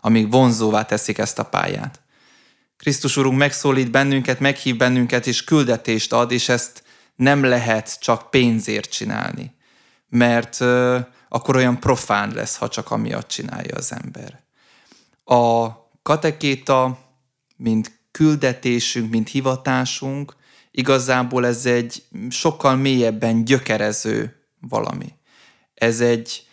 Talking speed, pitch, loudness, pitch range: 110 wpm, 125 Hz, -19 LUFS, 115-135 Hz